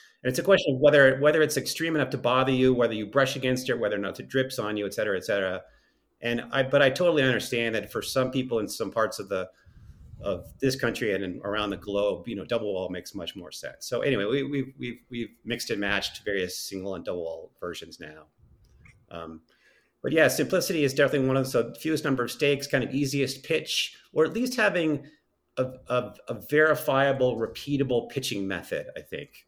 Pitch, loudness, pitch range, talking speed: 130 Hz, -26 LUFS, 120-145 Hz, 220 wpm